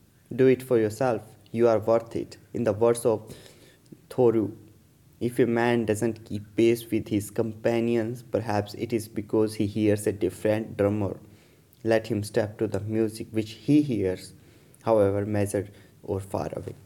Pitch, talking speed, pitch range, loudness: 110 Hz, 160 wpm, 105-115 Hz, -26 LUFS